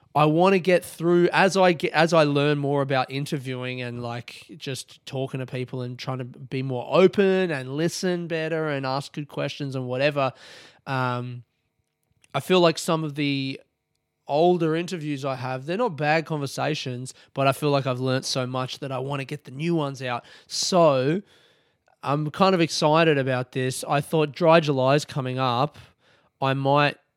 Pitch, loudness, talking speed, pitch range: 140 Hz, -24 LUFS, 185 wpm, 130-160 Hz